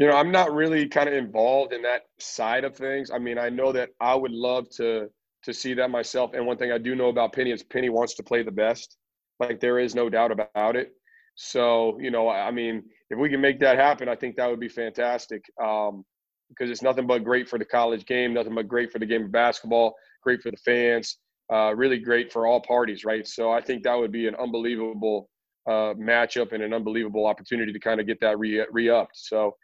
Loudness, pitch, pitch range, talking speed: -25 LUFS, 120 Hz, 115-125 Hz, 235 wpm